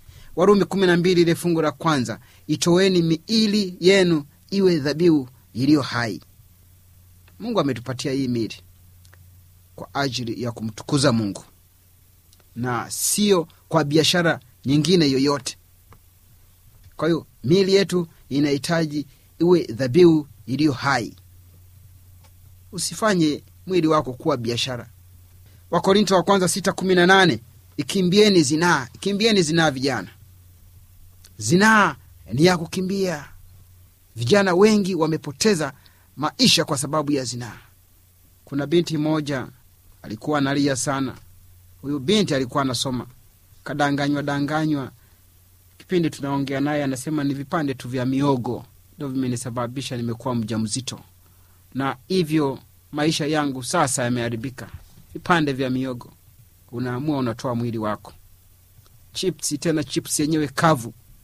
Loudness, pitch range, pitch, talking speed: -21 LUFS, 100-160 Hz, 135 Hz, 95 wpm